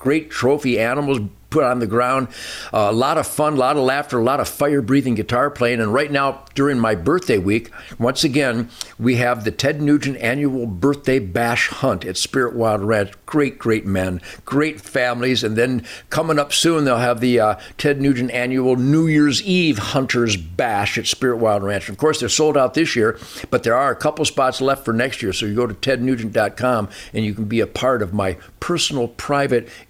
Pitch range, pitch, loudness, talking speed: 110-140 Hz, 125 Hz, -19 LUFS, 210 wpm